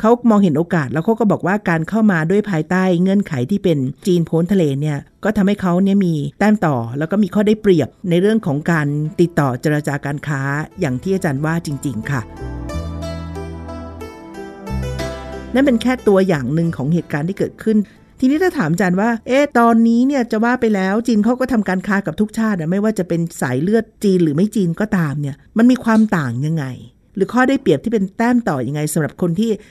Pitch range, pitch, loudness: 145-215 Hz, 180 Hz, -17 LUFS